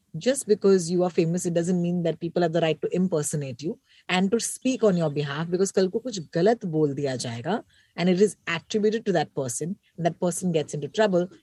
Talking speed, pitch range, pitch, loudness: 215 wpm, 160-195 Hz, 175 Hz, -25 LUFS